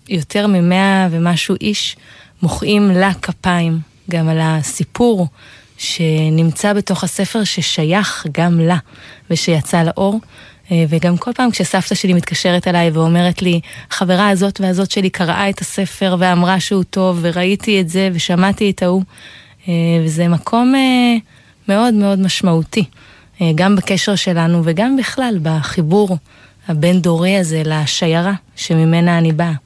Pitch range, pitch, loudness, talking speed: 165-195 Hz, 180 Hz, -15 LUFS, 125 wpm